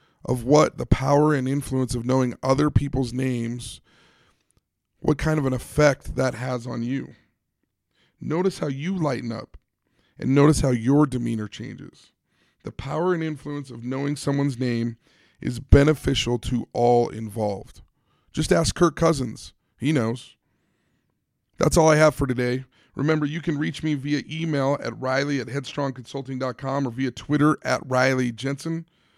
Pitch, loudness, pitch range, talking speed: 135 Hz, -23 LUFS, 125-150 Hz, 150 wpm